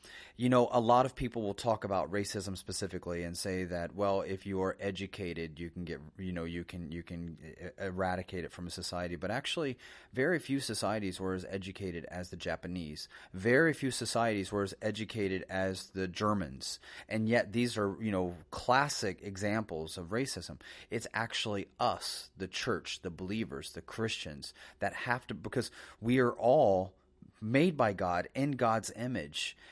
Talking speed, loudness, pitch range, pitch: 170 wpm, -34 LUFS, 90-110 Hz, 95 Hz